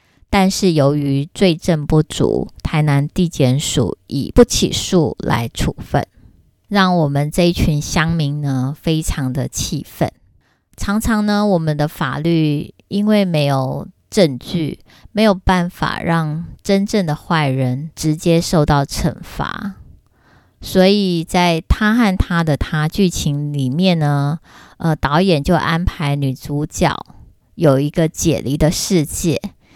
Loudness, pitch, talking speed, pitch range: -17 LUFS, 160 Hz, 190 characters per minute, 145-180 Hz